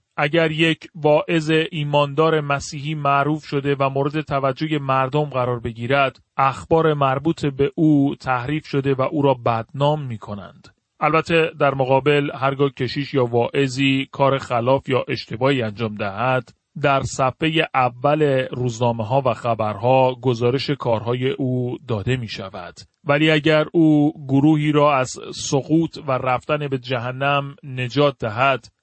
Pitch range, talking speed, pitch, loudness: 125-150 Hz, 135 wpm, 140 Hz, -20 LUFS